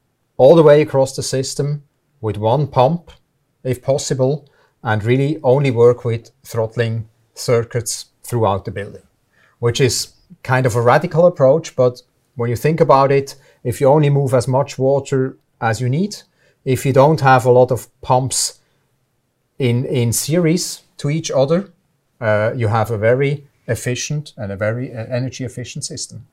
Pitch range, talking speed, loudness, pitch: 120-145 Hz, 160 wpm, -17 LUFS, 130 Hz